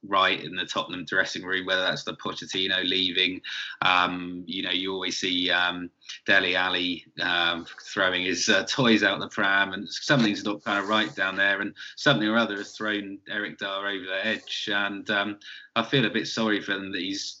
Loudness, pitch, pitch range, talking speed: -25 LUFS, 100 Hz, 90-105 Hz, 200 wpm